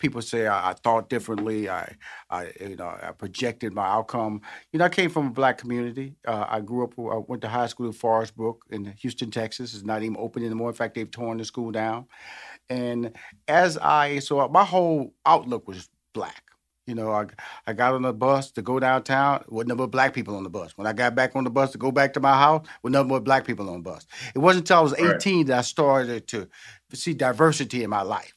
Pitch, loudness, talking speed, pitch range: 125 Hz, -24 LUFS, 240 wpm, 110-135 Hz